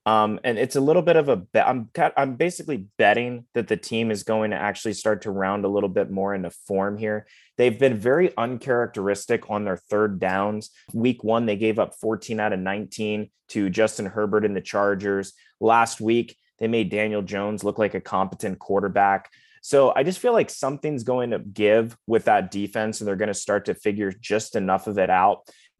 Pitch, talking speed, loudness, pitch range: 110 Hz, 205 wpm, -23 LUFS, 100-115 Hz